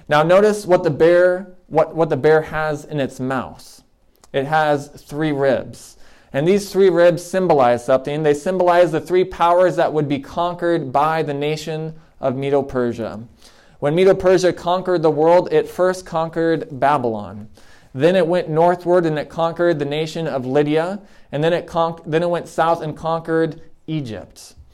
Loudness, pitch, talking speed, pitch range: -18 LUFS, 160 Hz, 170 wpm, 145-175 Hz